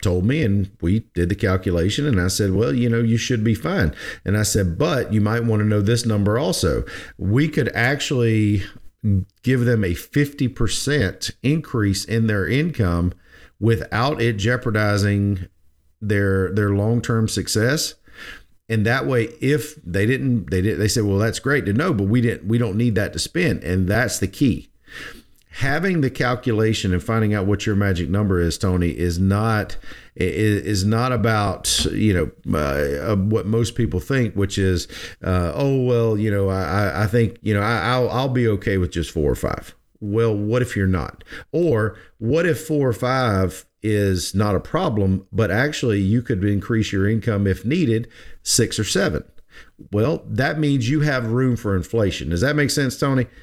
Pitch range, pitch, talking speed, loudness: 95-120 Hz, 110 Hz, 180 wpm, -20 LUFS